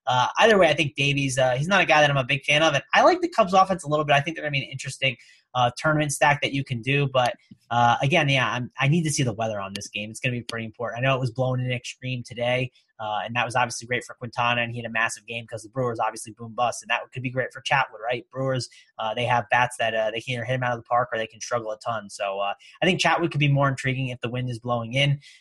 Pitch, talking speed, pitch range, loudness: 125 Hz, 315 wpm, 120-140 Hz, -24 LUFS